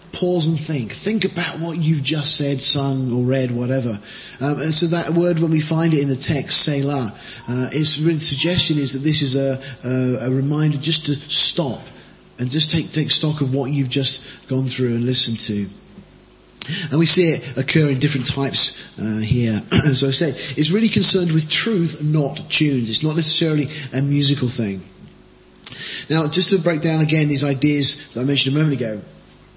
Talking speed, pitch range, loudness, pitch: 195 wpm, 130-160 Hz, -15 LUFS, 145 Hz